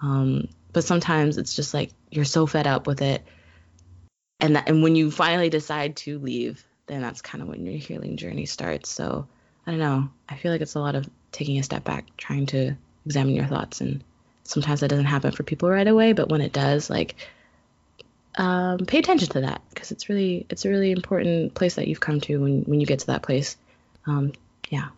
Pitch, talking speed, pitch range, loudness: 150 Hz, 215 wpm, 140-170 Hz, -24 LUFS